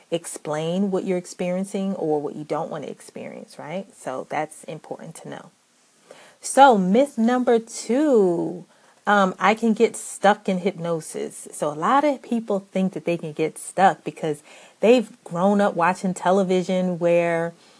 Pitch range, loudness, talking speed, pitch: 170-220 Hz, -22 LUFS, 155 wpm, 190 Hz